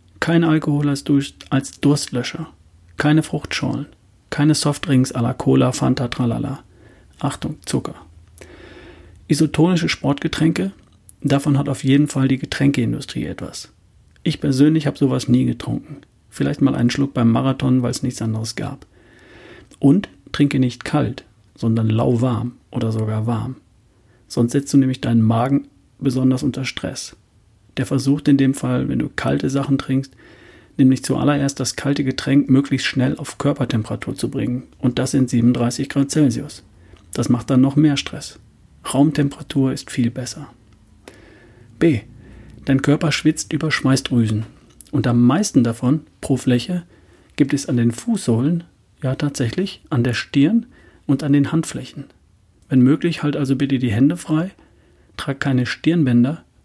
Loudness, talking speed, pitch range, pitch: -19 LUFS, 140 wpm, 120-145 Hz, 135 Hz